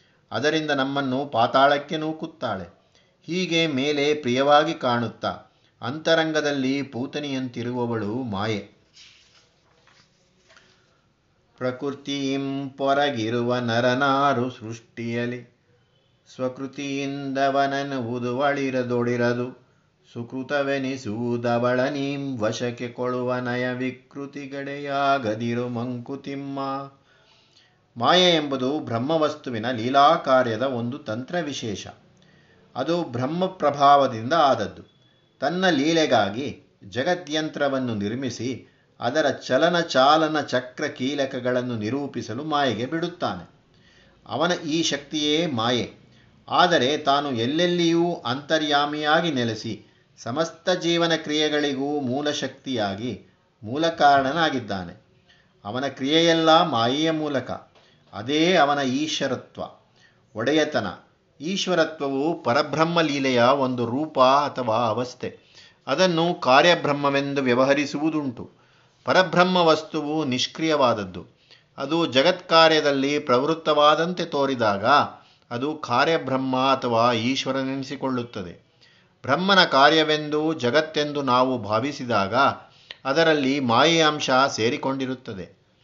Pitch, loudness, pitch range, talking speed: 140 Hz, -22 LUFS, 125-155 Hz, 70 wpm